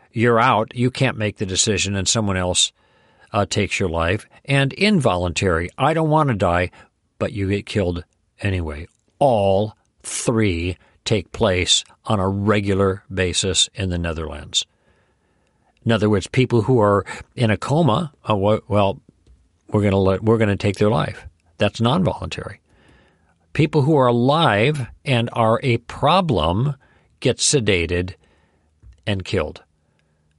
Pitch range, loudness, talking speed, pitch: 90-115 Hz, -19 LUFS, 140 wpm, 100 Hz